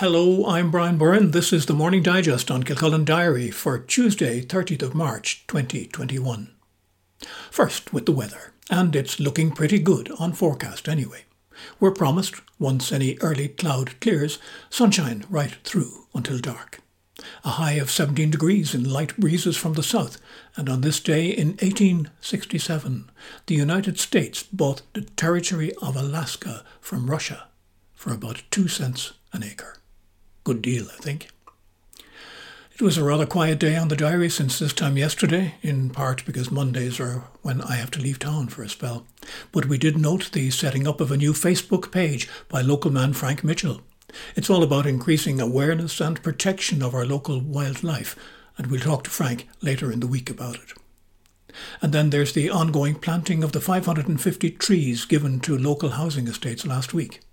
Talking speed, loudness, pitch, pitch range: 170 wpm, -23 LUFS, 150 Hz, 130-170 Hz